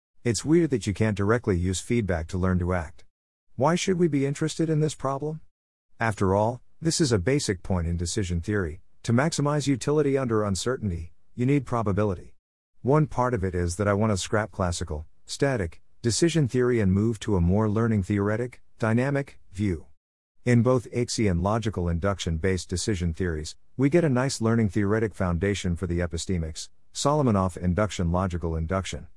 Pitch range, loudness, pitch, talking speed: 90-125 Hz, -26 LUFS, 105 Hz, 170 wpm